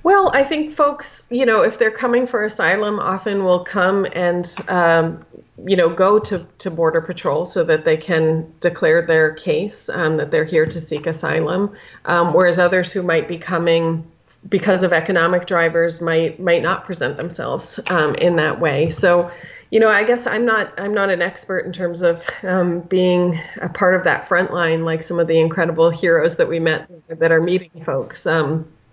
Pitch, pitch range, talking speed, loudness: 175 Hz, 165-195 Hz, 190 wpm, -18 LUFS